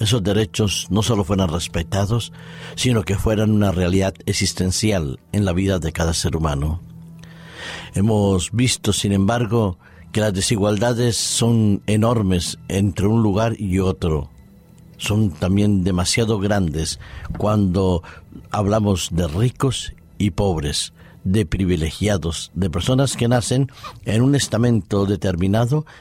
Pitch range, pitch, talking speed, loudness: 90-115 Hz, 100 Hz, 120 wpm, -20 LUFS